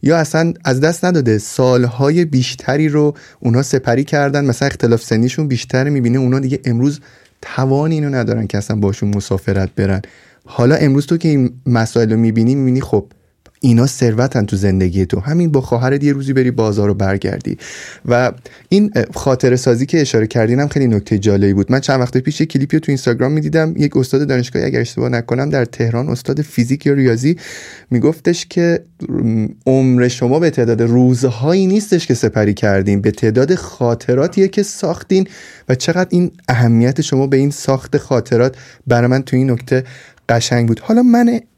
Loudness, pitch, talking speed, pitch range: -15 LUFS, 130 Hz, 170 wpm, 115-145 Hz